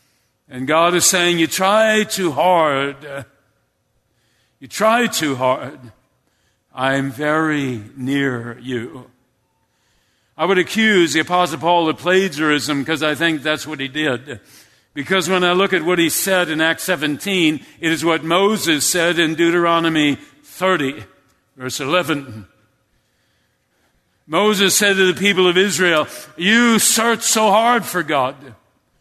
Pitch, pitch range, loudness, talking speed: 160 Hz, 140-185 Hz, -16 LUFS, 135 wpm